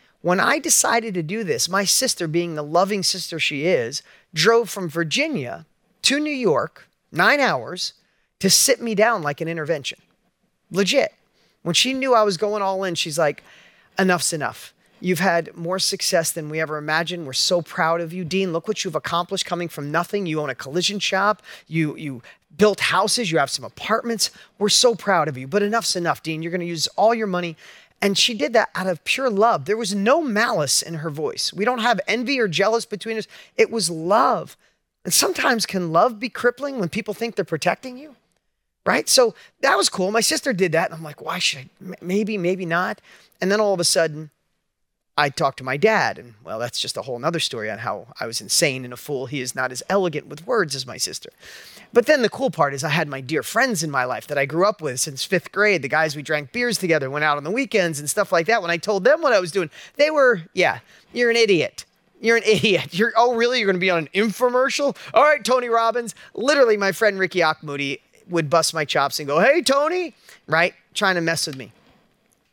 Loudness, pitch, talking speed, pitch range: -20 LUFS, 190 Hz, 225 wpm, 165-225 Hz